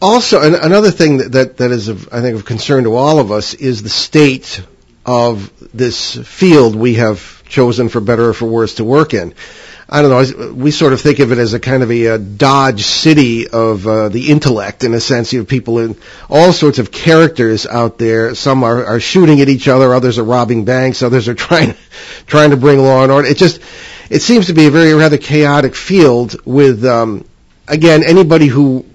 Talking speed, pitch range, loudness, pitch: 210 wpm, 115-150 Hz, -10 LUFS, 130 Hz